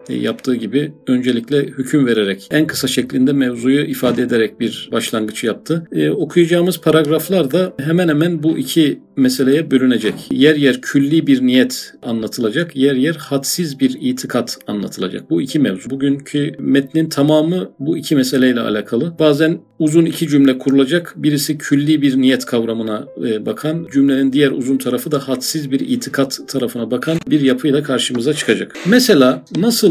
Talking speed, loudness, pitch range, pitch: 145 wpm, -16 LUFS, 130-160 Hz, 140 Hz